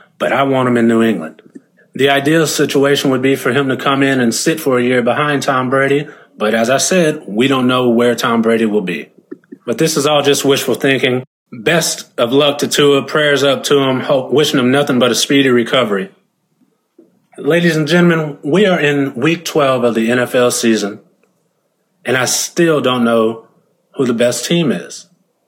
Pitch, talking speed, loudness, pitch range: 135 Hz, 195 wpm, -13 LUFS, 120-145 Hz